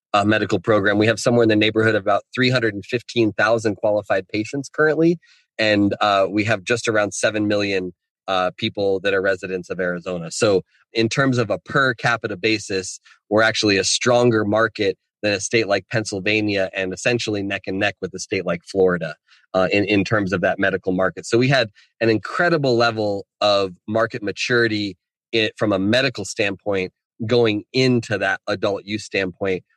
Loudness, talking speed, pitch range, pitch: -20 LUFS, 175 wpm, 95-115 Hz, 105 Hz